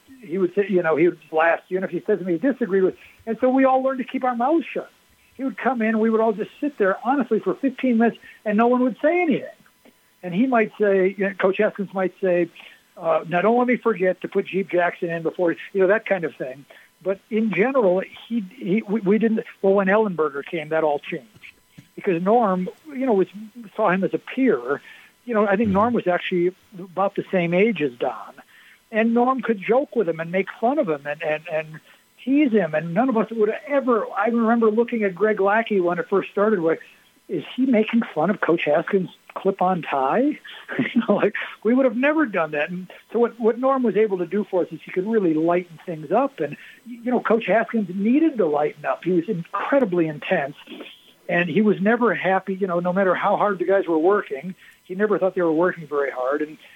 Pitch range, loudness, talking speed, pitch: 180-230 Hz, -22 LUFS, 235 wpm, 200 Hz